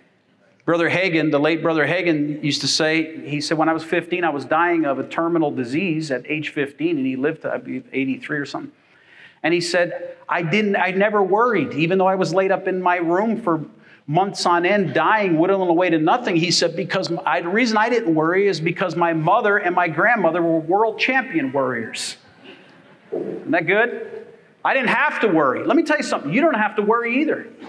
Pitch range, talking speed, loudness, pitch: 160-205 Hz, 210 wpm, -19 LUFS, 175 Hz